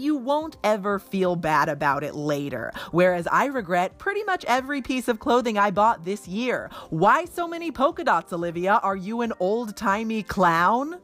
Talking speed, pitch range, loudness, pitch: 180 wpm, 180-270 Hz, -24 LUFS, 215 Hz